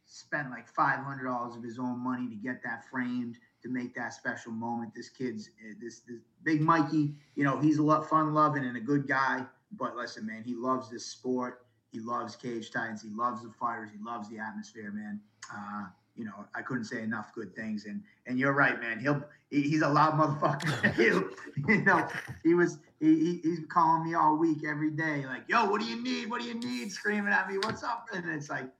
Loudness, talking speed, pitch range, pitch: -31 LUFS, 220 wpm, 120-155 Hz, 130 Hz